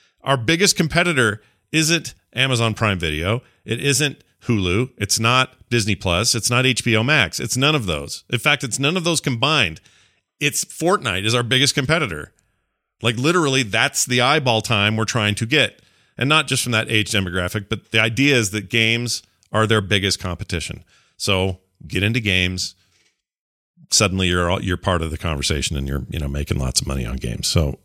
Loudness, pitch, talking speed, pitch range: -19 LUFS, 110 Hz, 185 wpm, 95-130 Hz